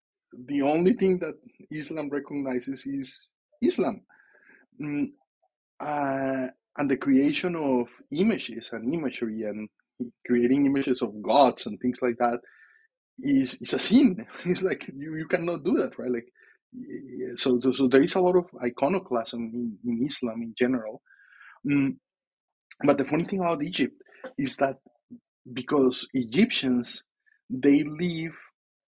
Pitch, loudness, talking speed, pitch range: 145 Hz, -26 LUFS, 135 wpm, 125-190 Hz